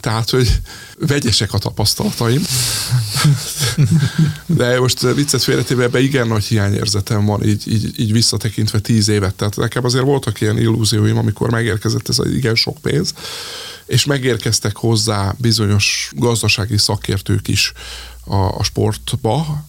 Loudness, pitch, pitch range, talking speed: -16 LUFS, 115 Hz, 105-125 Hz, 130 wpm